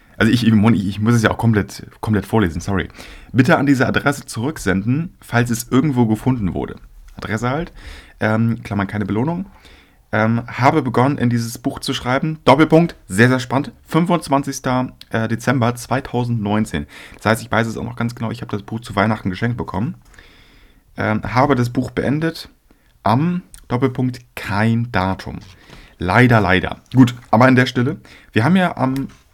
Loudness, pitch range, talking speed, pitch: -18 LUFS, 105-130 Hz, 165 wpm, 115 Hz